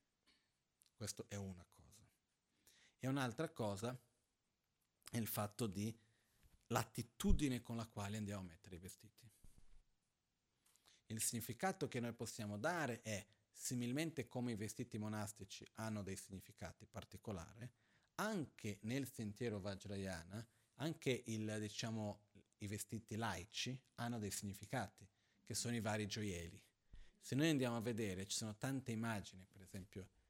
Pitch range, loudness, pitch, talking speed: 100-120 Hz, -46 LUFS, 110 Hz, 130 wpm